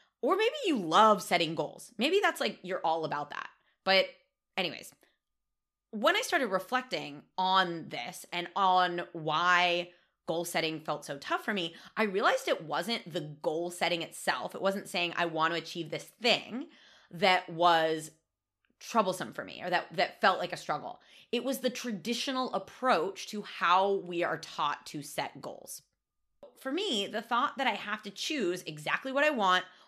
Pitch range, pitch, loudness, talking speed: 170-235 Hz, 185 Hz, -31 LUFS, 175 wpm